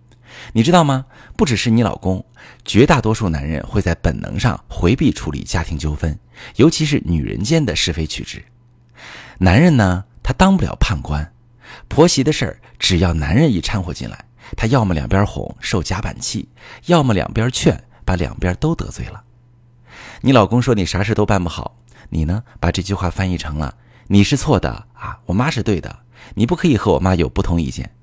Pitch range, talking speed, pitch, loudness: 90-125 Hz, 275 characters per minute, 110 Hz, -17 LUFS